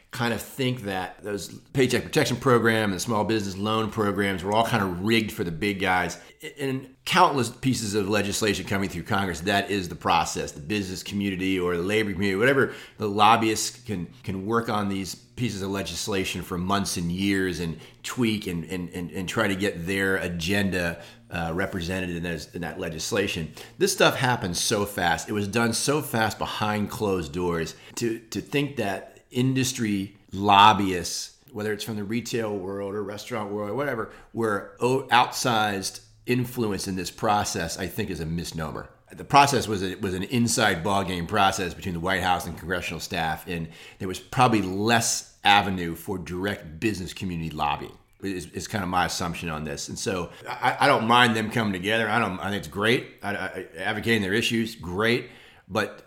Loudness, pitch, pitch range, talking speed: -25 LUFS, 100 Hz, 90-115 Hz, 185 wpm